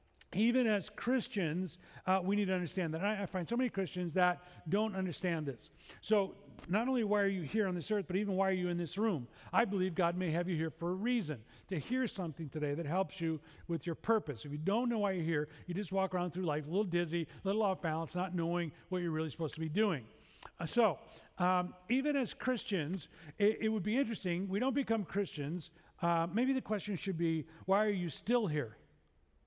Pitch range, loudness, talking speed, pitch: 165-210 Hz, -36 LUFS, 230 wpm, 185 Hz